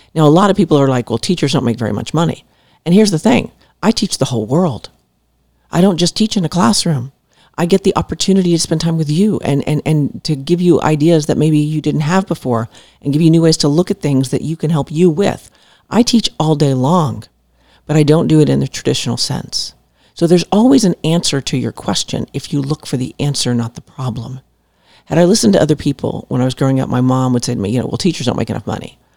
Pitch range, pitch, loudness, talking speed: 130-175 Hz, 150 Hz, -14 LUFS, 255 wpm